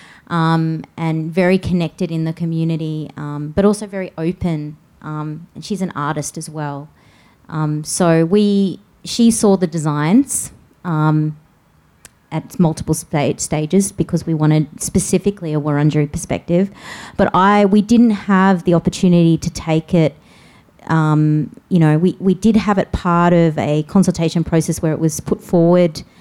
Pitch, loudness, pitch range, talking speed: 165 Hz, -16 LUFS, 155-185 Hz, 150 wpm